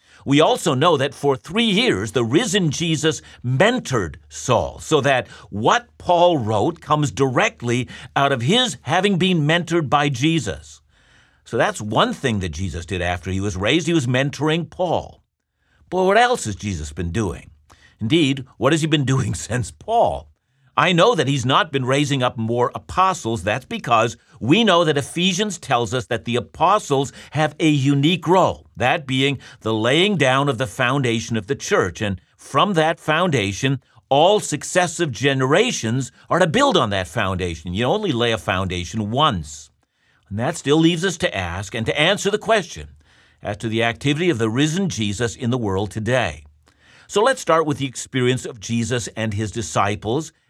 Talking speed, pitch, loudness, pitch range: 175 wpm, 130 Hz, -19 LUFS, 110-160 Hz